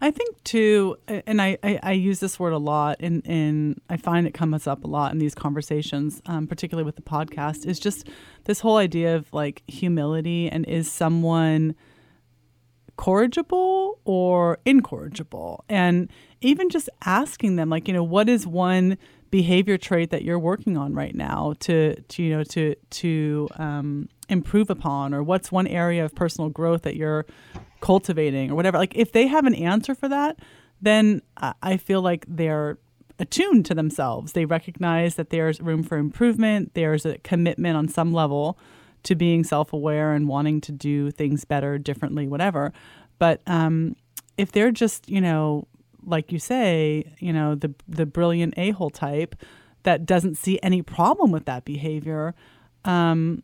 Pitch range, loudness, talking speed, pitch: 150-190 Hz, -23 LUFS, 170 wpm, 165 Hz